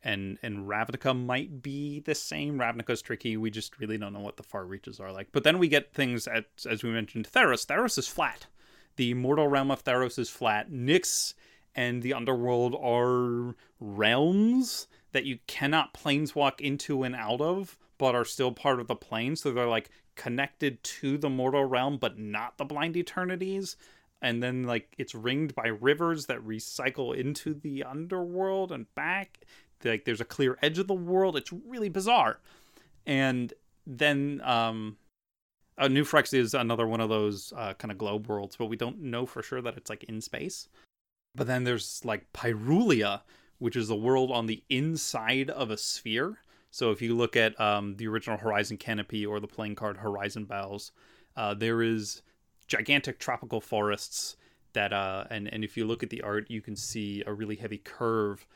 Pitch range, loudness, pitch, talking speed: 110-140 Hz, -30 LUFS, 120 Hz, 185 wpm